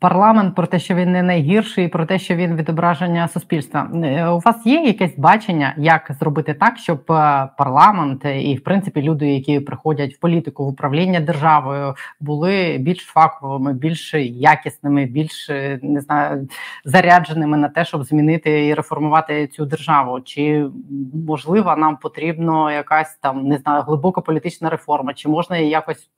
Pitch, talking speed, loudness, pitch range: 155 Hz, 150 wpm, -17 LUFS, 145-170 Hz